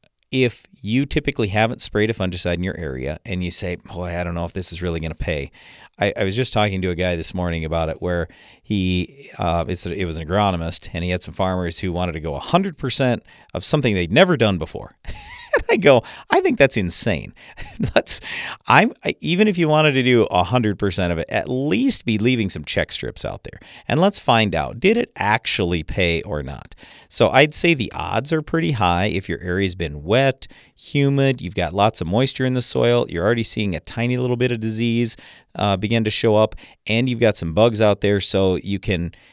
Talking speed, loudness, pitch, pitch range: 225 wpm, -20 LUFS, 100 Hz, 90-125 Hz